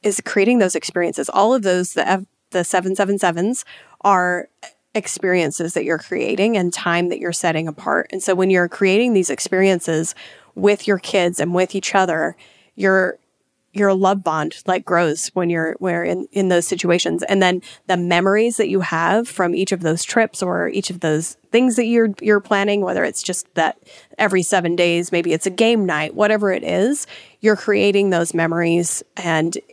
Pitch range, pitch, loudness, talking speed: 175-200 Hz, 185 Hz, -18 LUFS, 185 wpm